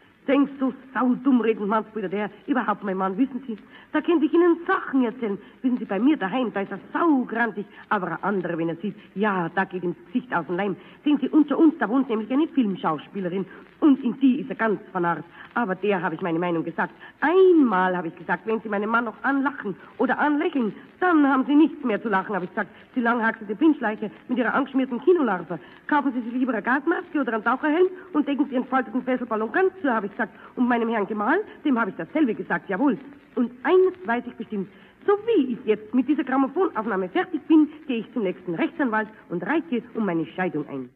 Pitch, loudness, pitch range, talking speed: 235 Hz, -24 LUFS, 200-280 Hz, 215 wpm